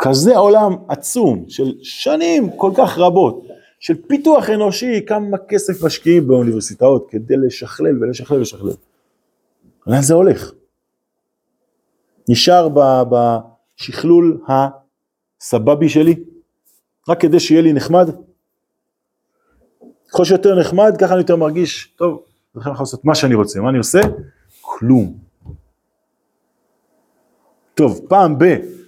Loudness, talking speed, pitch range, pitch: -14 LUFS, 110 wpm, 130-190 Hz, 160 Hz